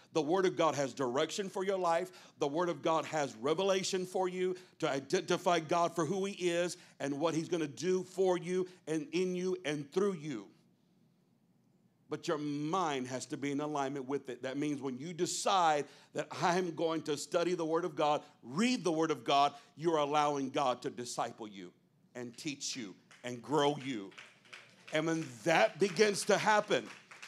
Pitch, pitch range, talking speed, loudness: 160 Hz, 145-180 Hz, 185 wpm, -34 LUFS